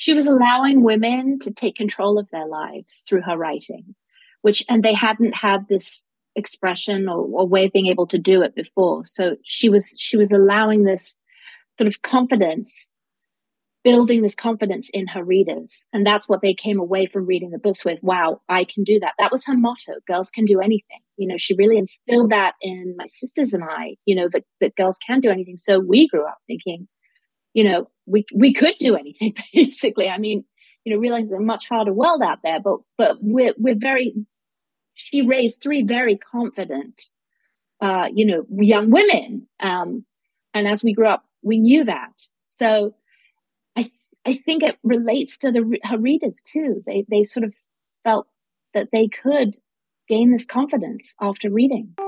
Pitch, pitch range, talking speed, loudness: 215 Hz, 195-245 Hz, 190 wpm, -19 LUFS